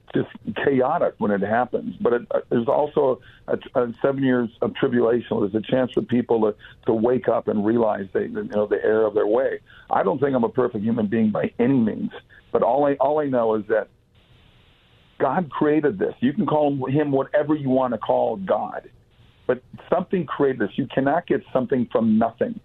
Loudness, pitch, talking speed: -22 LUFS, 140 Hz, 205 wpm